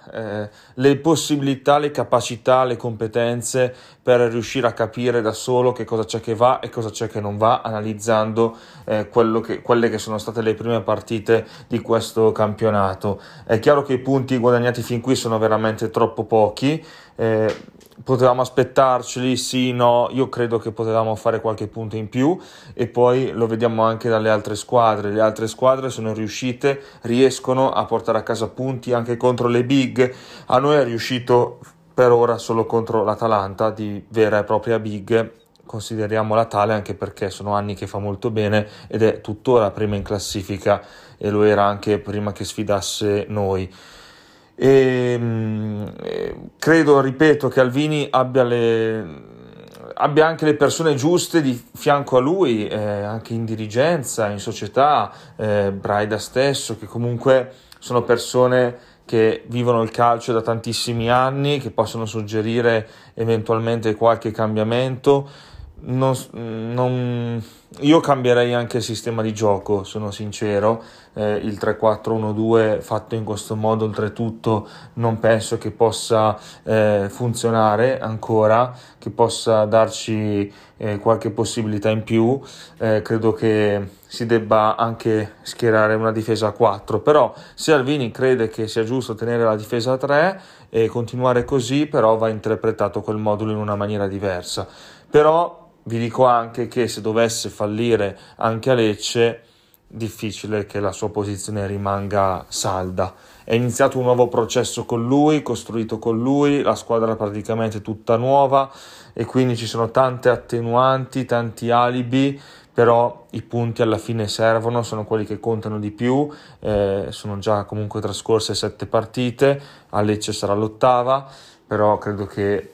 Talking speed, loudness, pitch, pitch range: 150 wpm, -20 LUFS, 115 Hz, 110-125 Hz